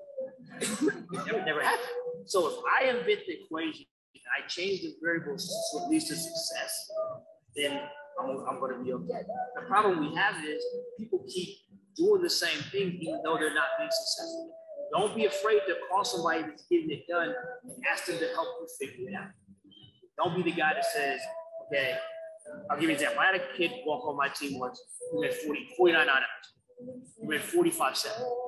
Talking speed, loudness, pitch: 195 wpm, -30 LUFS, 290 Hz